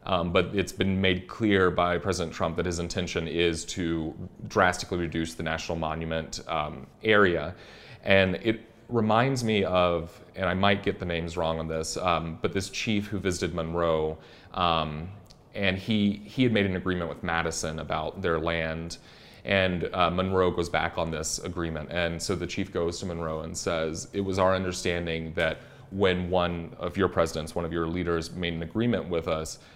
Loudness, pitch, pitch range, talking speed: -28 LUFS, 85 Hz, 80-95 Hz, 185 wpm